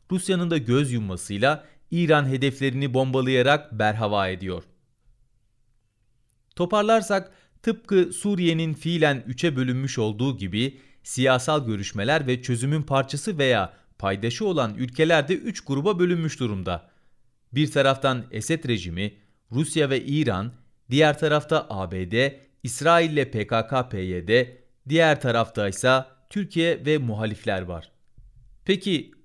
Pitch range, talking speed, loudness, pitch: 115-155 Hz, 105 wpm, -24 LUFS, 130 Hz